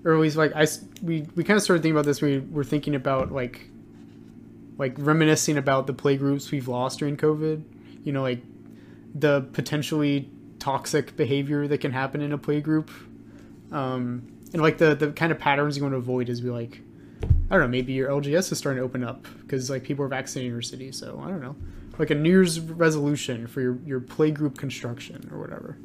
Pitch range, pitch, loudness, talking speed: 130-155 Hz, 145 Hz, -25 LUFS, 210 wpm